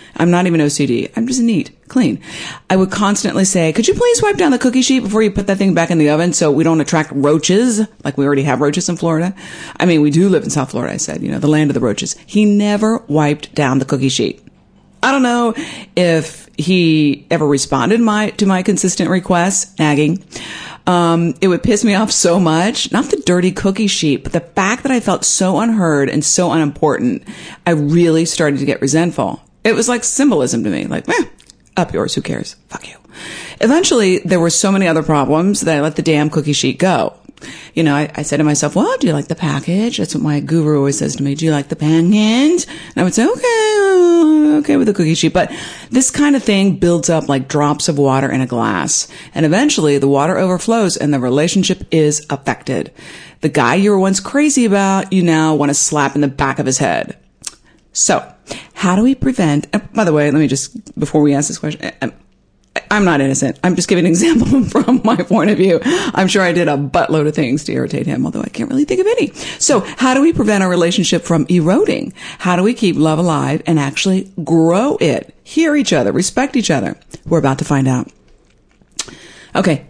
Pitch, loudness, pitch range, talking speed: 175 Hz, -14 LUFS, 150-215 Hz, 220 wpm